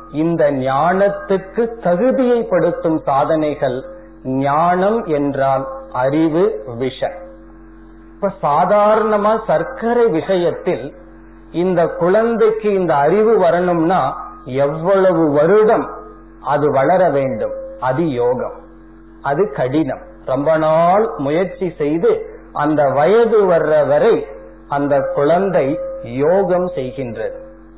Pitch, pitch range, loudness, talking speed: 160 Hz, 135-195 Hz, -16 LUFS, 80 wpm